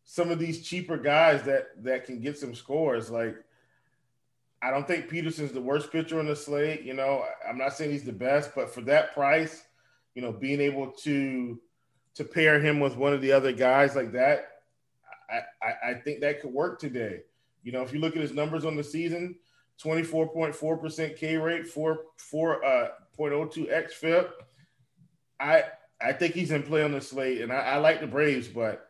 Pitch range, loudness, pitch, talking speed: 135-160 Hz, -28 LUFS, 150 Hz, 195 wpm